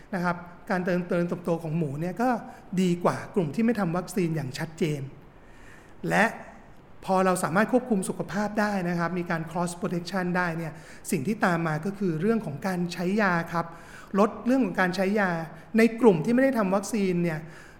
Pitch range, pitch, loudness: 170-210 Hz, 185 Hz, -26 LUFS